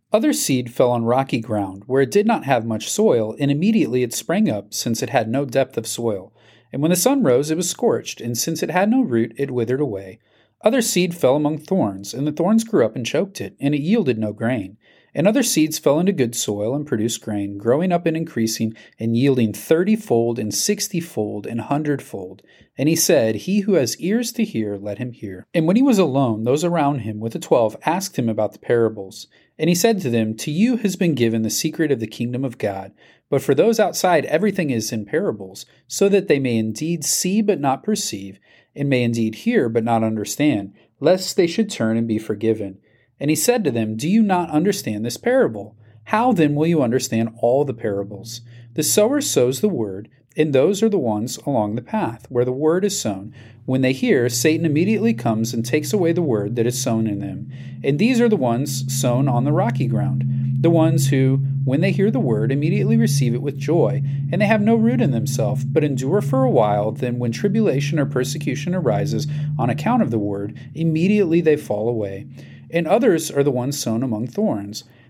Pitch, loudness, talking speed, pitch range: 135 Hz, -20 LUFS, 215 wpm, 115-165 Hz